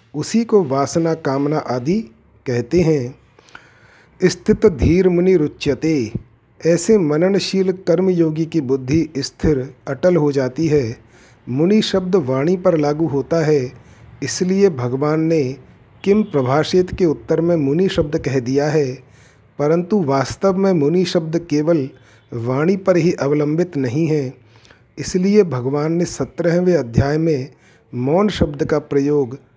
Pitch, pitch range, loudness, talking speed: 155 Hz, 135-175 Hz, -17 LUFS, 130 wpm